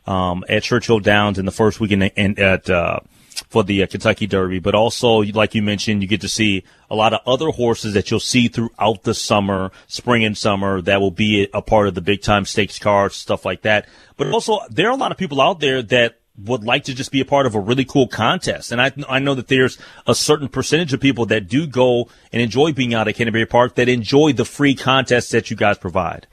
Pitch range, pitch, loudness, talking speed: 105-125 Hz, 110 Hz, -17 LUFS, 245 wpm